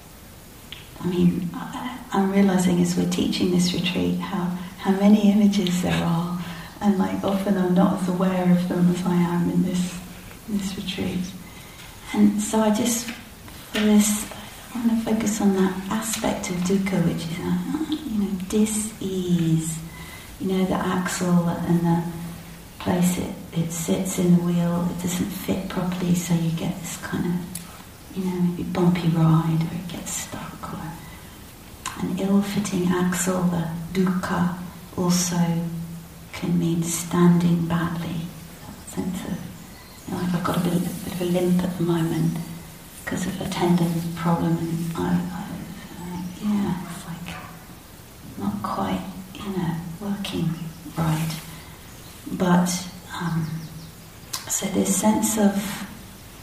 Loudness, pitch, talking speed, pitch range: -23 LUFS, 180 Hz, 145 wpm, 170-195 Hz